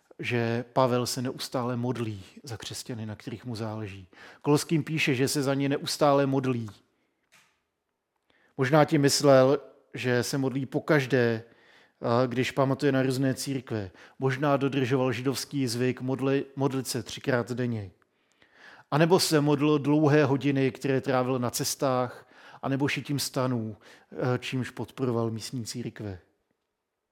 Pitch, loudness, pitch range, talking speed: 130 Hz, -27 LUFS, 120-140 Hz, 130 wpm